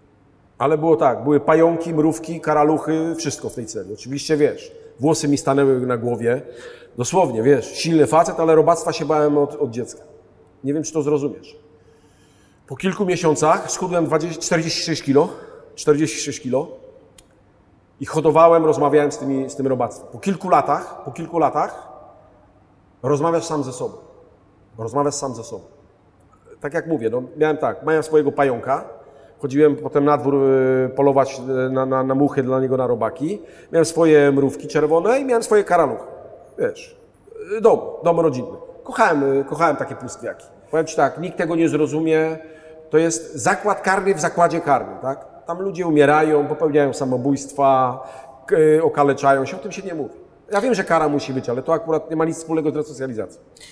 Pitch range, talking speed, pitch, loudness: 135-165 Hz, 160 wpm, 150 Hz, -19 LUFS